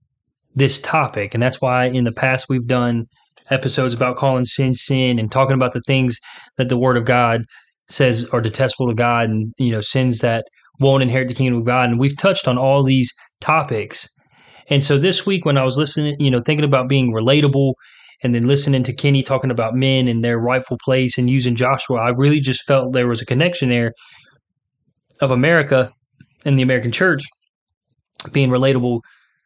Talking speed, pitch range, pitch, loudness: 190 wpm, 125-135 Hz, 130 Hz, -17 LUFS